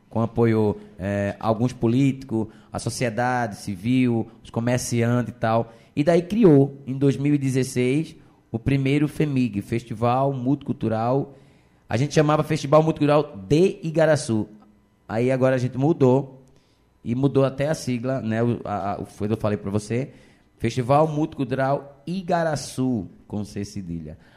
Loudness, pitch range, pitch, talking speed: -23 LUFS, 110-140 Hz, 125 Hz, 140 wpm